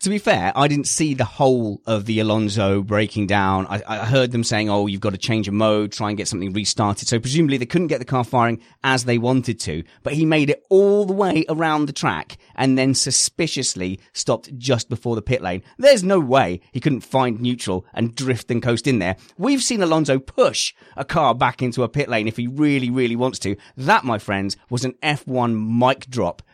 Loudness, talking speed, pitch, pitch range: -20 LUFS, 225 wpm, 125 Hz, 105-135 Hz